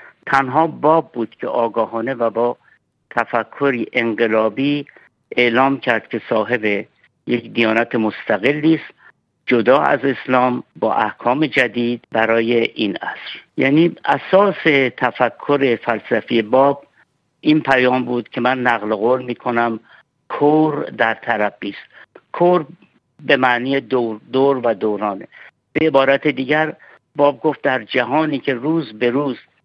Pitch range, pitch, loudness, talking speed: 120-145 Hz, 125 Hz, -17 LUFS, 125 wpm